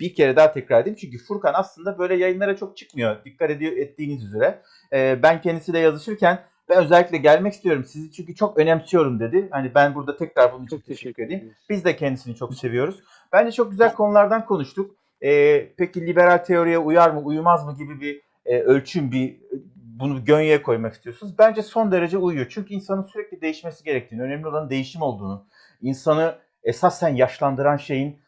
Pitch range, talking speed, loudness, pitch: 140-190 Hz, 170 wpm, -20 LUFS, 160 Hz